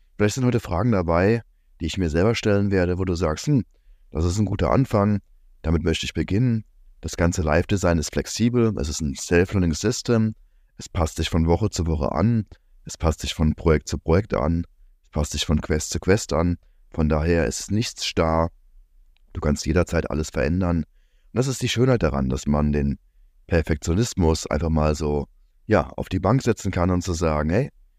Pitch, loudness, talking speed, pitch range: 85 Hz, -23 LUFS, 195 wpm, 75-100 Hz